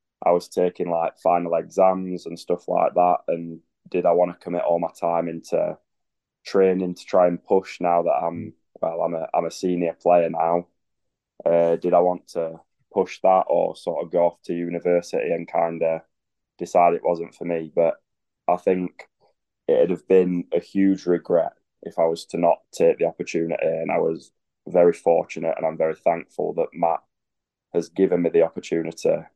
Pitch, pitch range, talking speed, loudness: 85 Hz, 85-90 Hz, 190 wpm, -22 LUFS